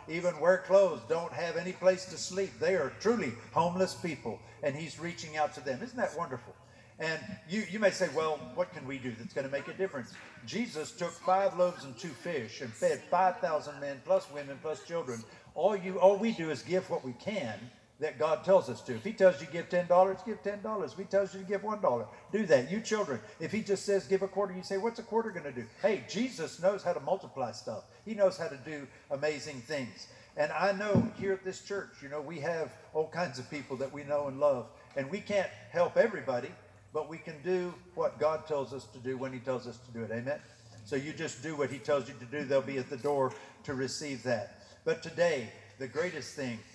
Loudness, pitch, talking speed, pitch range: -33 LUFS, 160 Hz, 235 wpm, 140-195 Hz